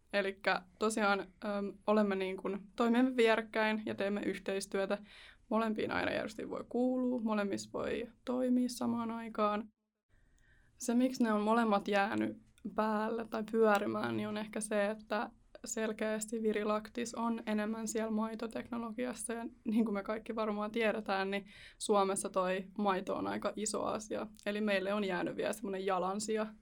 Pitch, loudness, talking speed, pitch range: 215 Hz, -35 LUFS, 140 wpm, 200-230 Hz